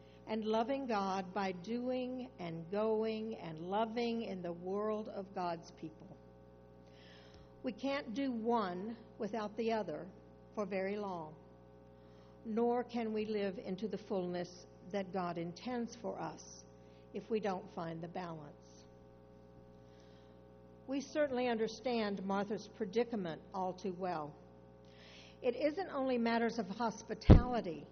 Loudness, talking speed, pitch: -38 LUFS, 125 wpm, 195 Hz